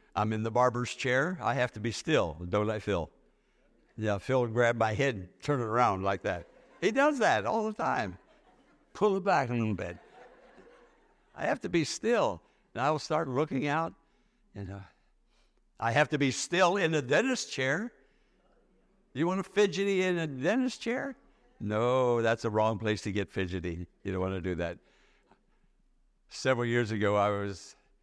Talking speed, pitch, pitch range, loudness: 180 wpm, 125 Hz, 105-160 Hz, -30 LUFS